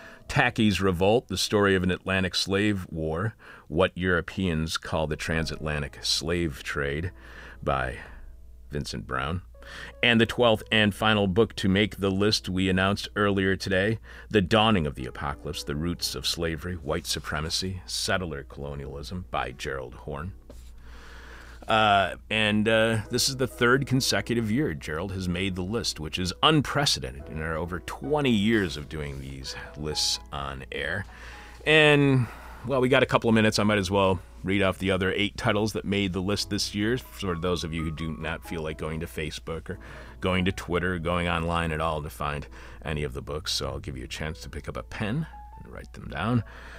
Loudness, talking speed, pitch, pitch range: -26 LUFS, 185 wpm, 90 Hz, 75-105 Hz